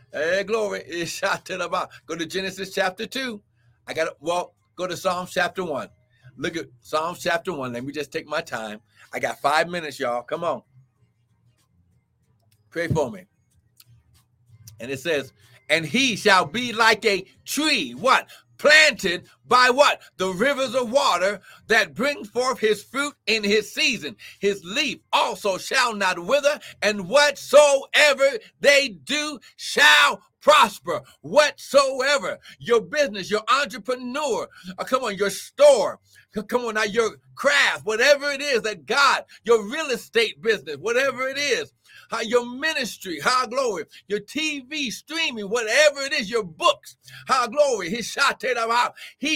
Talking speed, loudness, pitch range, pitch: 150 wpm, -21 LUFS, 165-275 Hz, 215 Hz